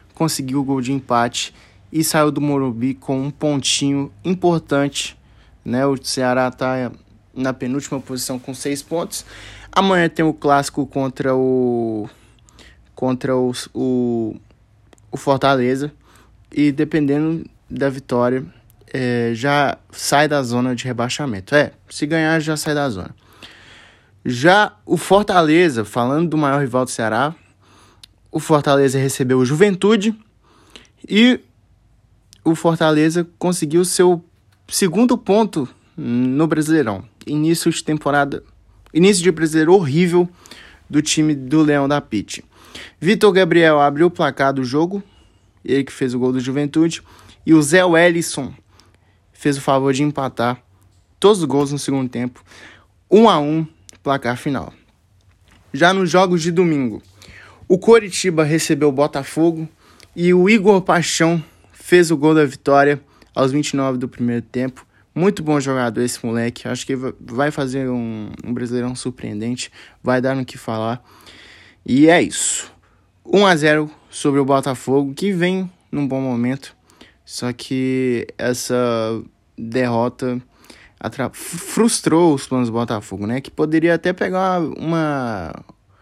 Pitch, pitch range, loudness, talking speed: 135 Hz, 120-160 Hz, -18 LUFS, 135 wpm